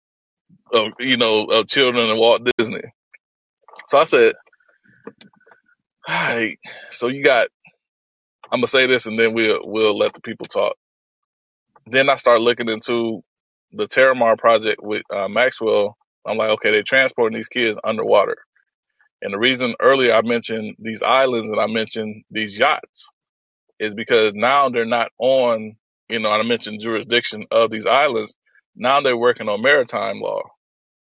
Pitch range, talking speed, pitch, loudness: 110-135 Hz, 155 wpm, 115 Hz, -18 LUFS